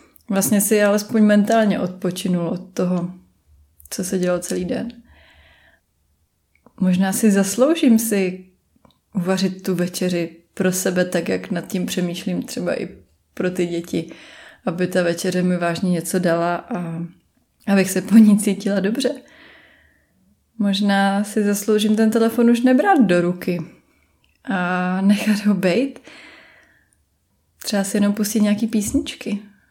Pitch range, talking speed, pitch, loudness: 180-215 Hz, 130 wpm, 190 Hz, -19 LUFS